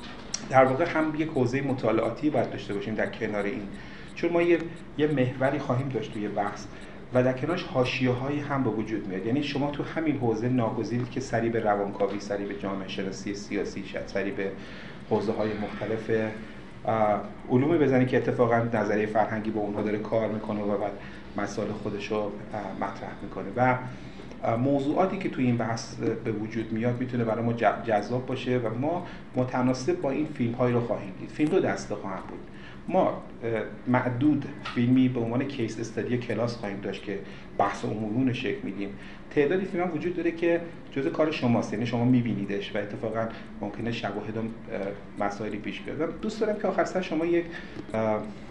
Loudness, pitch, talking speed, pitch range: -28 LUFS, 115 Hz, 170 wpm, 105-130 Hz